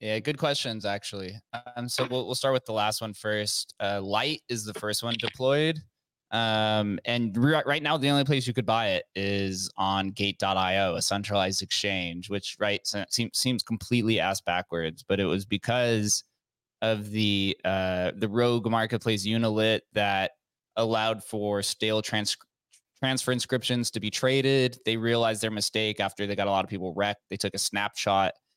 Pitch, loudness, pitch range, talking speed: 110 Hz, -27 LUFS, 100-120 Hz, 175 wpm